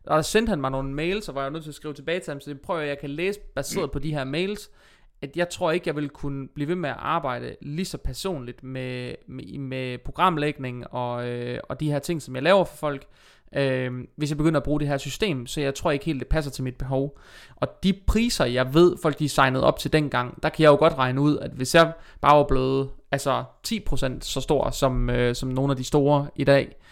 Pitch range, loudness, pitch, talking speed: 130-160 Hz, -25 LUFS, 145 Hz, 255 wpm